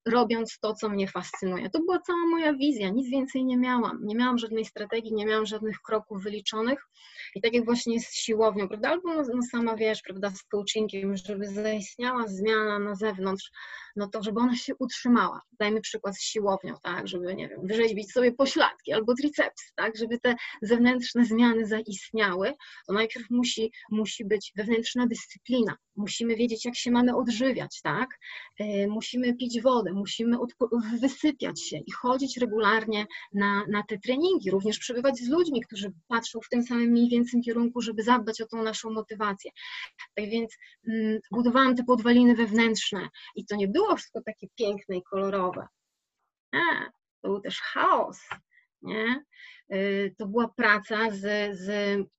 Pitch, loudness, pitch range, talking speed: 225 Hz, -27 LUFS, 205-245 Hz, 165 wpm